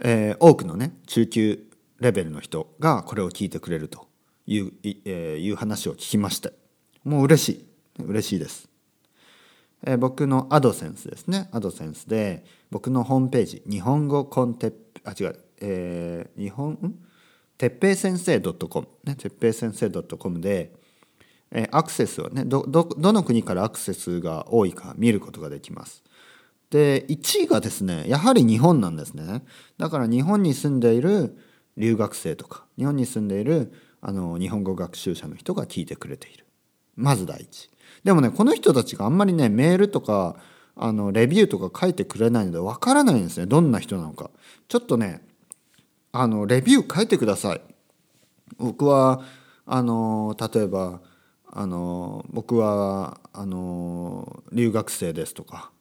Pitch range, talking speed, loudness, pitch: 100-145 Hz, 315 characters per minute, -23 LUFS, 115 Hz